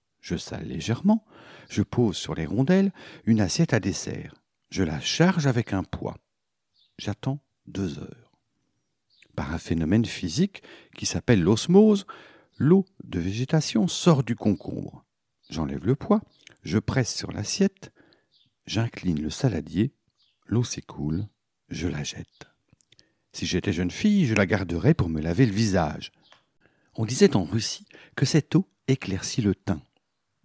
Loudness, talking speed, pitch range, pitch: -25 LUFS, 140 wpm, 95-160 Hz, 115 Hz